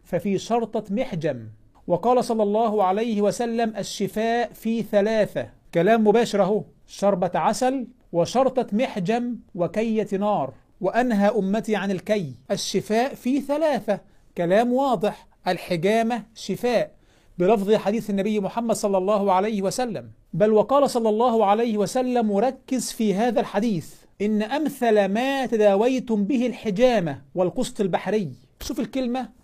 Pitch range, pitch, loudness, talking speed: 195-235 Hz, 215 Hz, -23 LUFS, 120 wpm